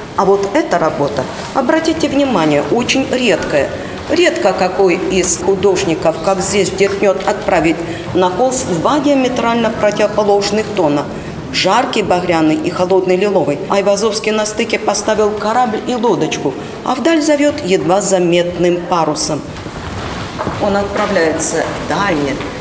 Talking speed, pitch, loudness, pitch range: 115 wpm, 200 Hz, -14 LUFS, 180-230 Hz